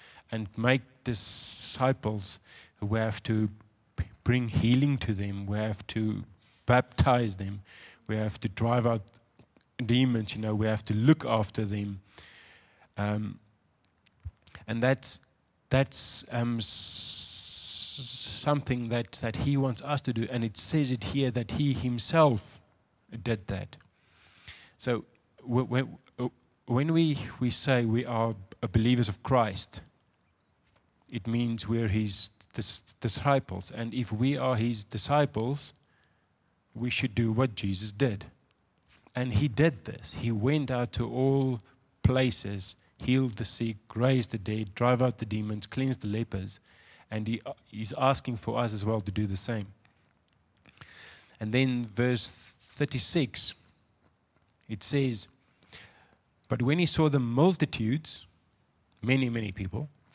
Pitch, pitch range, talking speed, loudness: 115 Hz, 105-125 Hz, 130 wpm, -29 LUFS